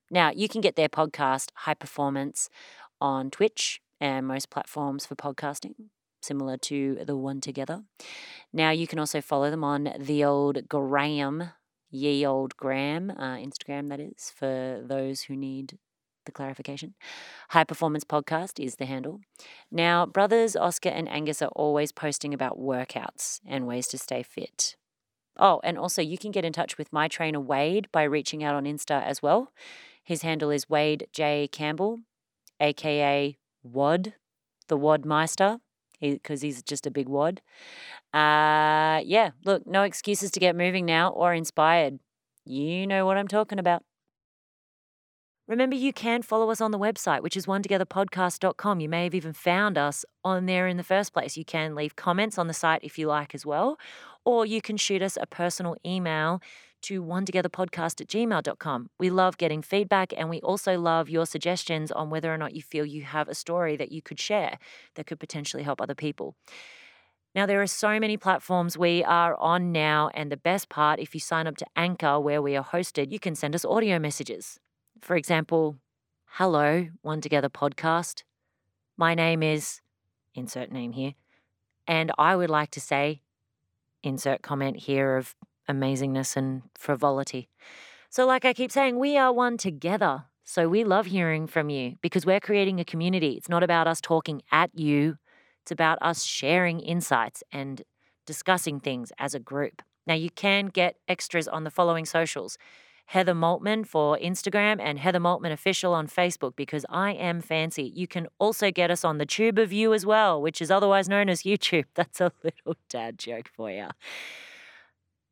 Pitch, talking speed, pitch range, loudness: 160 Hz, 175 wpm, 145-185 Hz, -26 LUFS